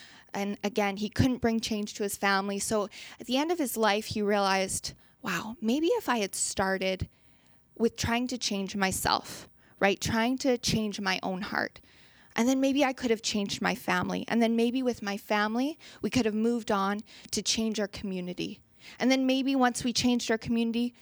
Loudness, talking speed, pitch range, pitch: -29 LUFS, 195 wpm, 200-245 Hz, 220 Hz